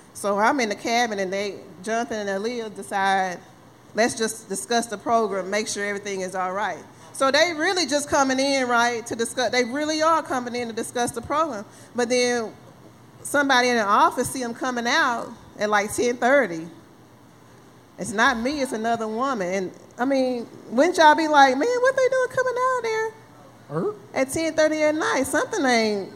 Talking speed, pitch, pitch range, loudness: 190 wpm, 245 Hz, 215-295 Hz, -22 LUFS